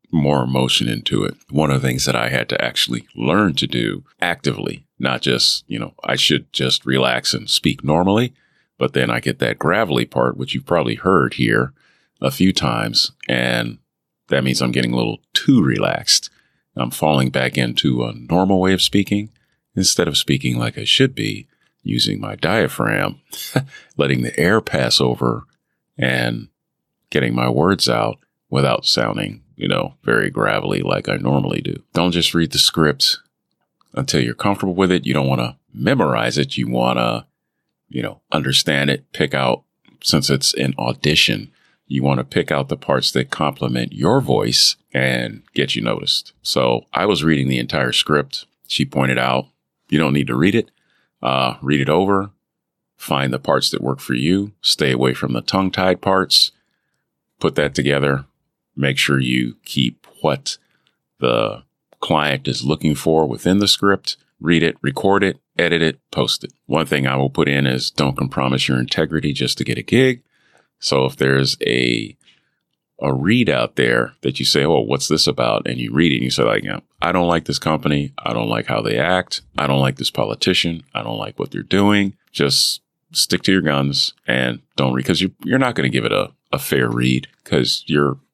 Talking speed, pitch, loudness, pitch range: 185 wpm, 70 Hz, -18 LUFS, 65-85 Hz